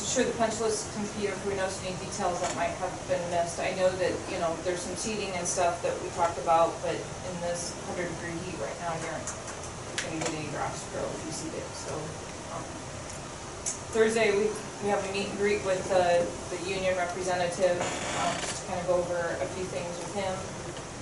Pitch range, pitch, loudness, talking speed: 175-195 Hz, 180 Hz, -30 LUFS, 210 wpm